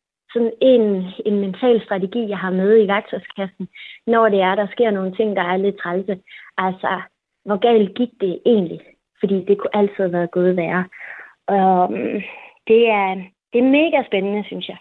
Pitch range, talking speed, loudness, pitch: 190-225 Hz, 180 wpm, -18 LUFS, 200 Hz